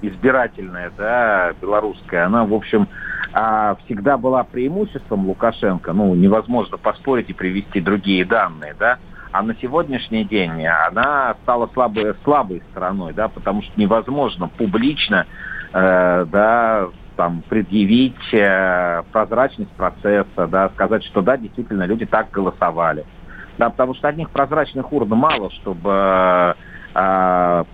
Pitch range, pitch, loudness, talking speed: 95-120 Hz, 105 Hz, -18 LUFS, 120 wpm